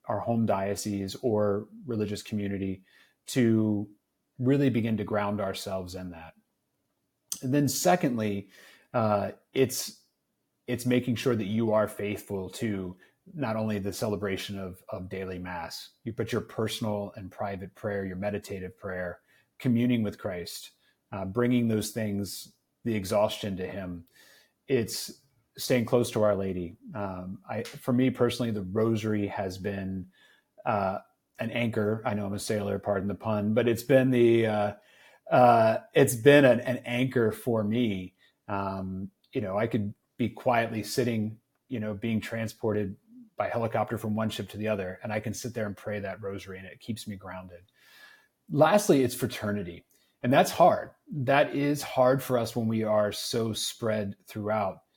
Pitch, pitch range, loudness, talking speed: 110 Hz, 100-120 Hz, -28 LUFS, 160 wpm